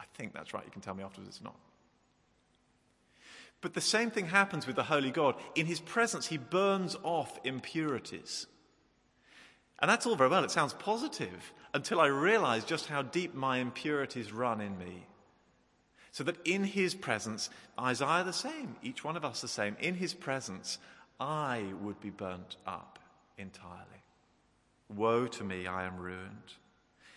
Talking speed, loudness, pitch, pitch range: 165 wpm, -34 LUFS, 125 Hz, 100-165 Hz